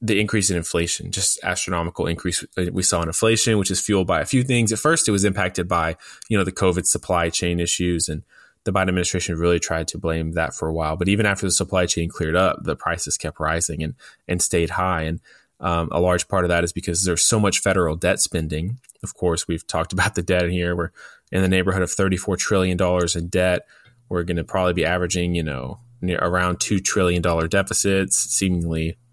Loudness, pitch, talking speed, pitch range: -21 LUFS, 90 Hz, 220 wpm, 85-95 Hz